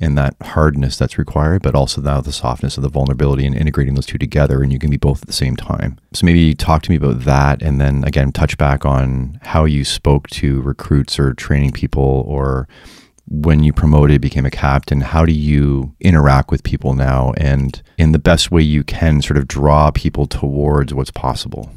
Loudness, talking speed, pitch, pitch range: -15 LUFS, 210 wpm, 70 Hz, 70-75 Hz